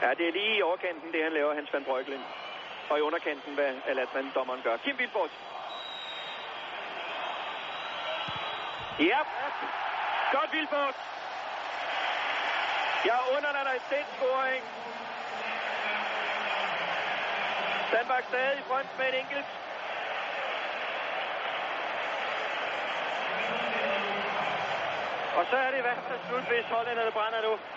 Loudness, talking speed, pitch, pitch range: -31 LUFS, 110 wpm, 255 Hz, 180-280 Hz